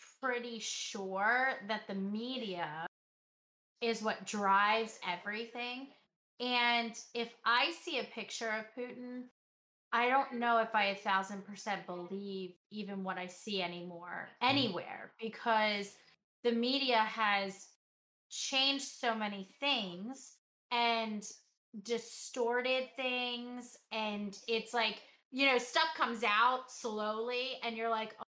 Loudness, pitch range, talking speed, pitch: -35 LUFS, 205-245 Hz, 120 wpm, 230 Hz